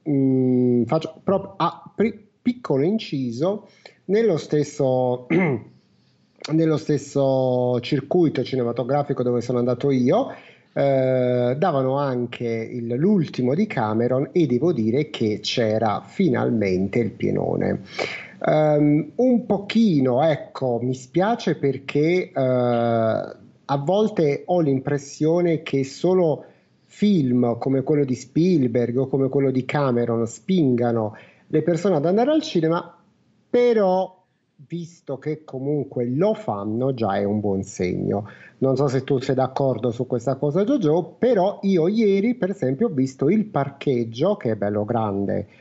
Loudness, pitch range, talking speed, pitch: -22 LUFS, 125-170 Hz, 125 wpm, 140 Hz